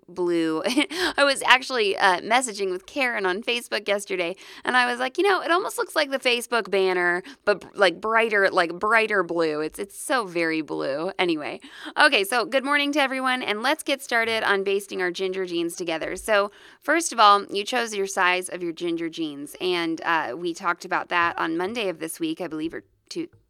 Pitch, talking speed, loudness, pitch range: 205 Hz, 205 wpm, -23 LUFS, 180-275 Hz